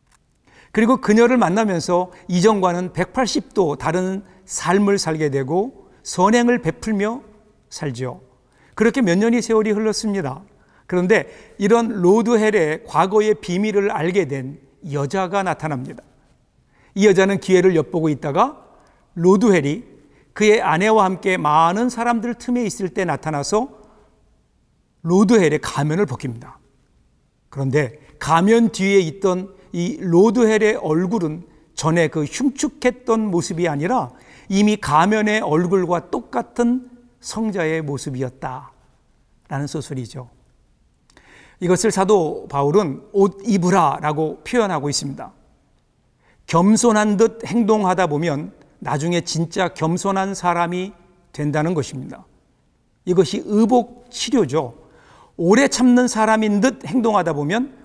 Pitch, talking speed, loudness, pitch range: 190 Hz, 255 characters per minute, -18 LUFS, 155-215 Hz